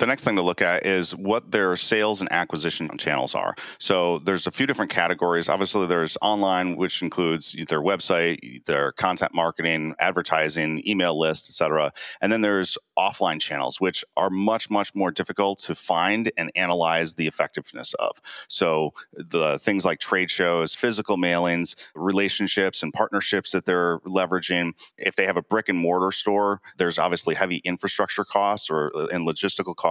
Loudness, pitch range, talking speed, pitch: -24 LUFS, 85-100 Hz, 170 wpm, 90 Hz